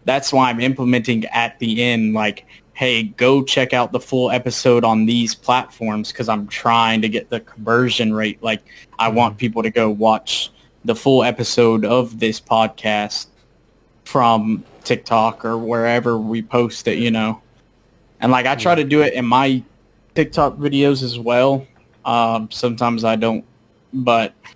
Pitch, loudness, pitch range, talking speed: 115 Hz, -17 LUFS, 110-125 Hz, 160 wpm